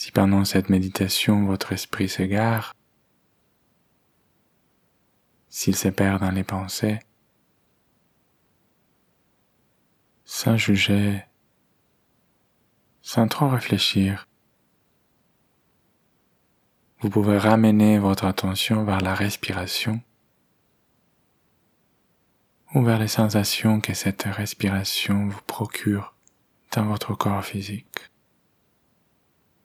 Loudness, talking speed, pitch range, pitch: -23 LUFS, 80 wpm, 95-110 Hz, 100 Hz